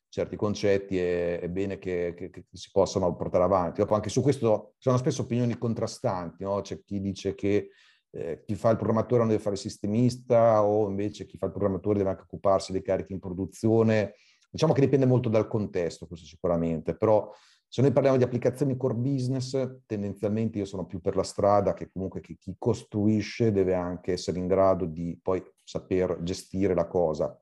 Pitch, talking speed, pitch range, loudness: 100 Hz, 190 wpm, 95-115 Hz, -27 LUFS